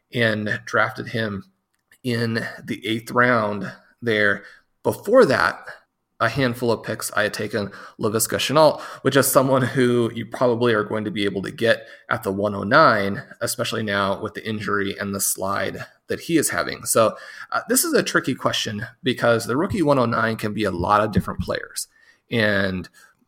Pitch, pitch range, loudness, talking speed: 110 Hz, 100-115 Hz, -21 LUFS, 170 wpm